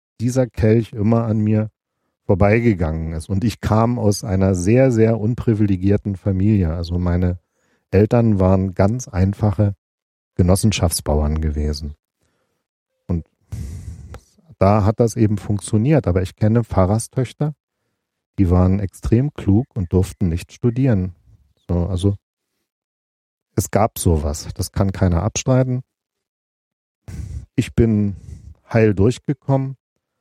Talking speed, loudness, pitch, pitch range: 105 wpm, -19 LUFS, 100 Hz, 90-115 Hz